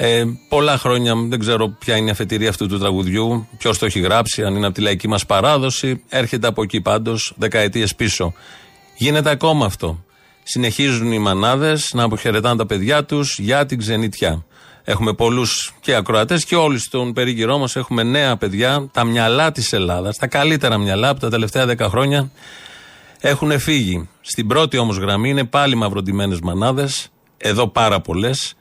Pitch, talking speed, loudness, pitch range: 115 Hz, 170 wpm, -17 LUFS, 105-135 Hz